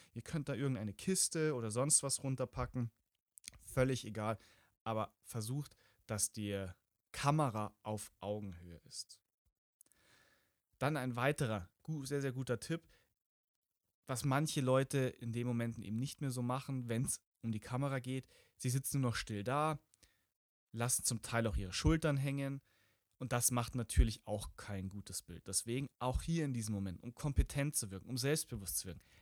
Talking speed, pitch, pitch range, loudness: 160 wpm, 120 Hz, 105-135 Hz, -38 LUFS